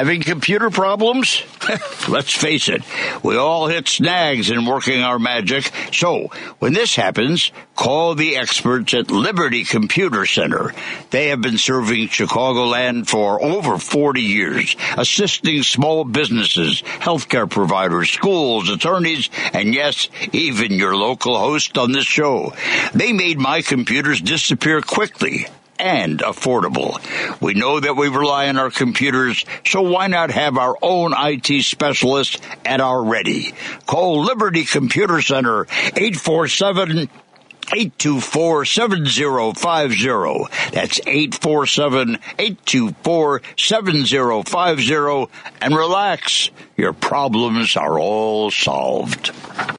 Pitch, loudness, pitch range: 145 Hz, -17 LUFS, 130-175 Hz